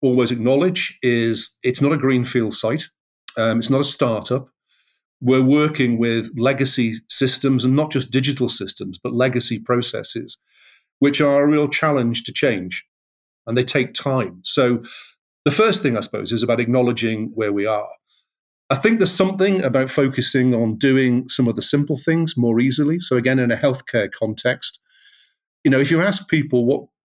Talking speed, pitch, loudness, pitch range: 170 wpm, 130 Hz, -19 LUFS, 120-145 Hz